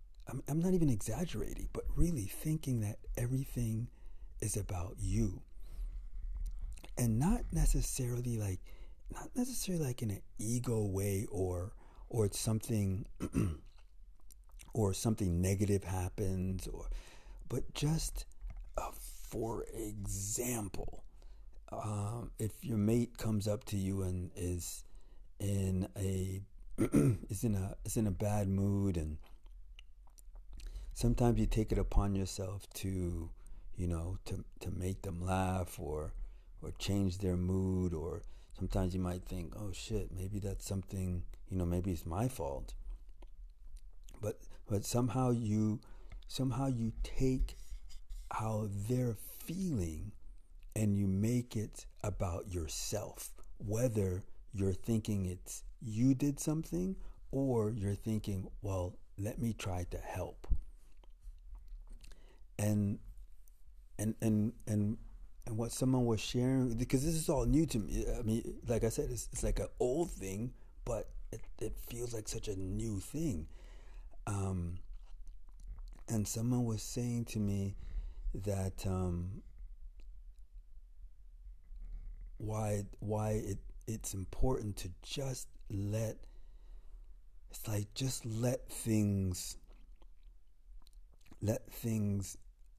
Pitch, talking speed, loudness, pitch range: 100 Hz, 120 wpm, -38 LUFS, 90-115 Hz